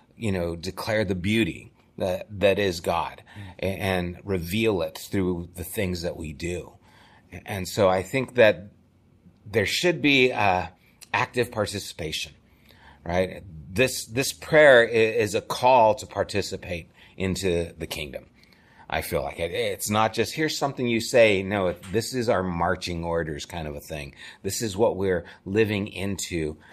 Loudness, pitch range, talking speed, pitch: -24 LUFS, 90-115 Hz, 150 wpm, 95 Hz